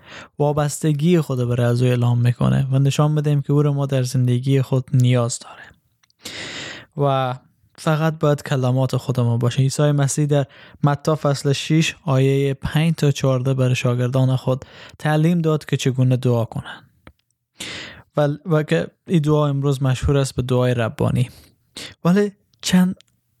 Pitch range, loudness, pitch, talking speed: 125-150 Hz, -19 LUFS, 135 Hz, 145 wpm